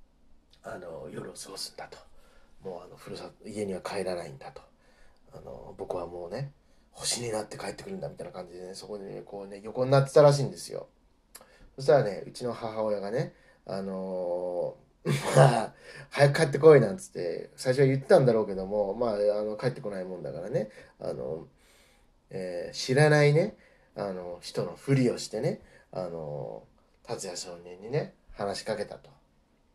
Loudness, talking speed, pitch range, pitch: -28 LUFS, 335 characters per minute, 95-140 Hz, 110 Hz